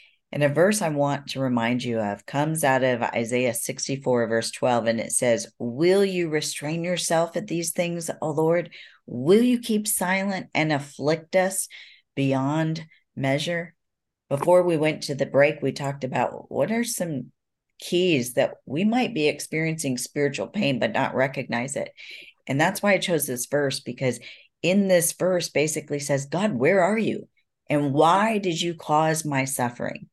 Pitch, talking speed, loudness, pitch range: 150 Hz, 170 wpm, -24 LUFS, 135-175 Hz